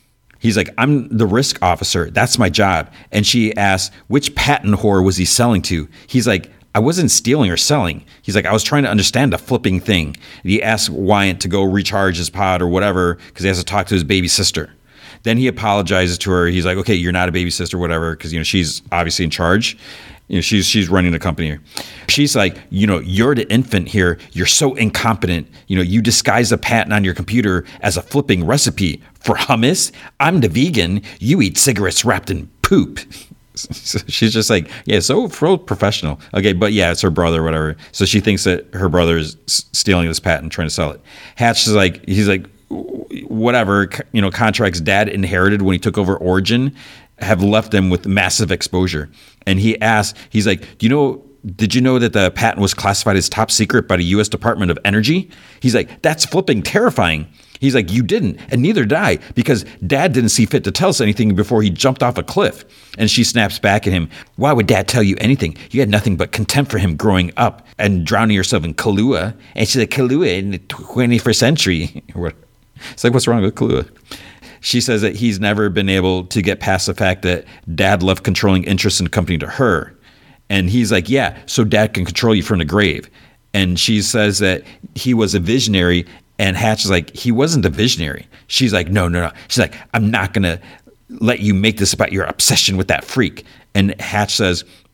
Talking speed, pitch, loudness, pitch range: 215 wpm, 100 Hz, -15 LUFS, 90-115 Hz